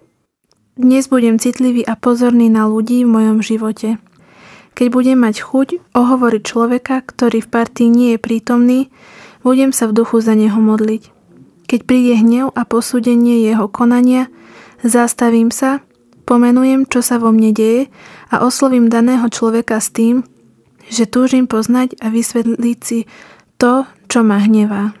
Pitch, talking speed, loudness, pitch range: 235 Hz, 145 wpm, -13 LUFS, 225-250 Hz